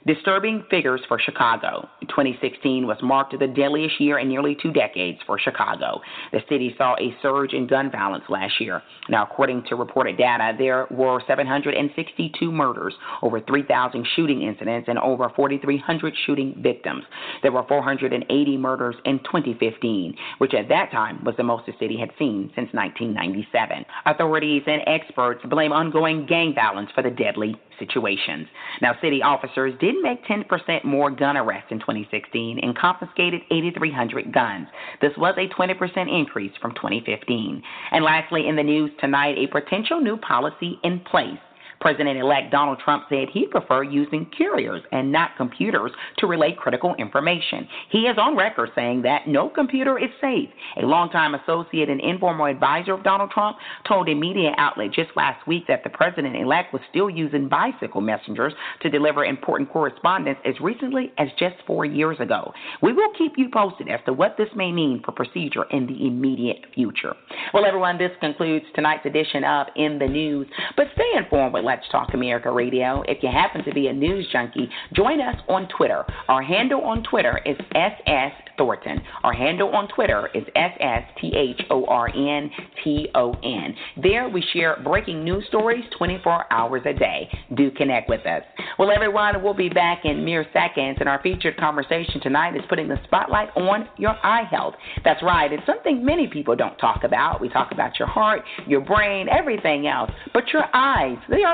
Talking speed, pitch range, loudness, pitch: 175 wpm, 135-180 Hz, -22 LUFS, 150 Hz